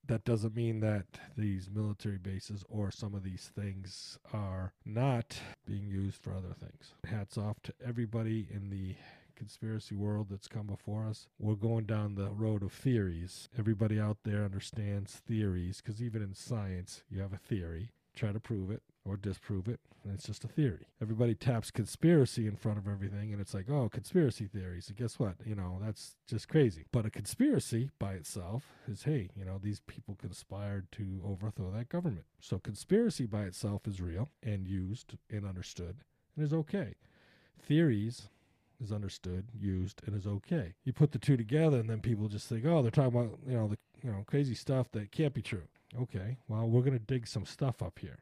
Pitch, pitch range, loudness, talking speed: 110 Hz, 100-120 Hz, -36 LUFS, 195 wpm